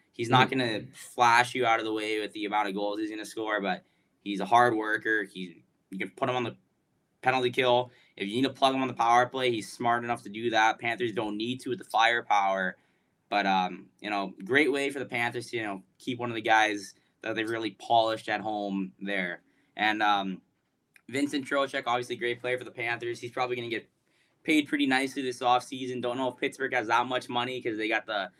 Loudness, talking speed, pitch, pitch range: -28 LUFS, 230 wpm, 115 Hz, 105-125 Hz